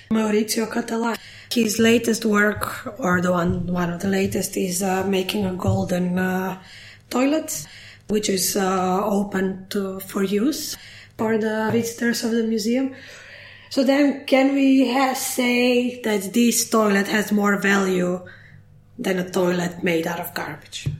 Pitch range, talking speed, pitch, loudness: 185-235 Hz, 145 wpm, 205 Hz, -21 LUFS